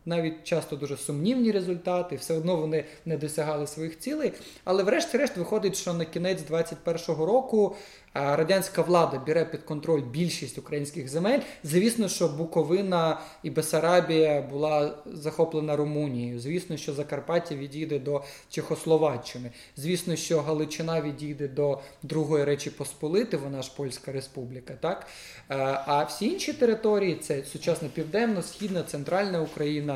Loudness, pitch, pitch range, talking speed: -28 LUFS, 160 Hz, 145-175 Hz, 130 wpm